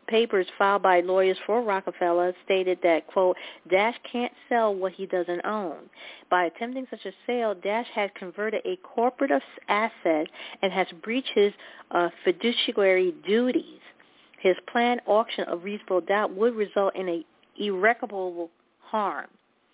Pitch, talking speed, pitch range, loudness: 200 Hz, 140 wpm, 185-230 Hz, -26 LUFS